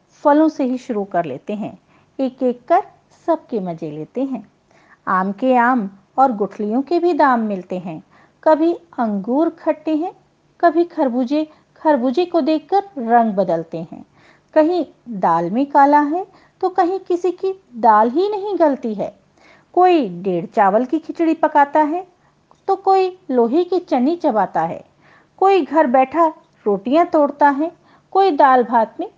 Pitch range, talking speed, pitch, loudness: 235-340 Hz, 155 wpm, 290 Hz, -17 LUFS